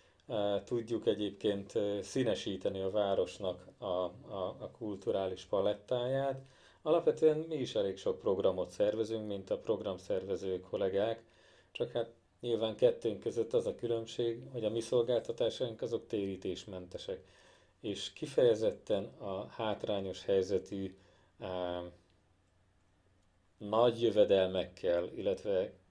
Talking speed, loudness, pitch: 100 wpm, -35 LUFS, 115 Hz